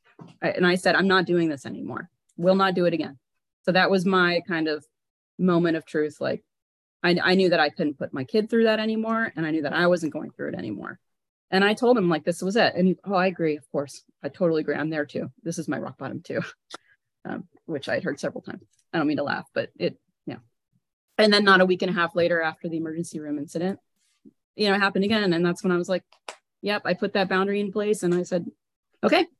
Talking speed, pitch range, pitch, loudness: 250 wpm, 165-195 Hz, 180 Hz, -24 LUFS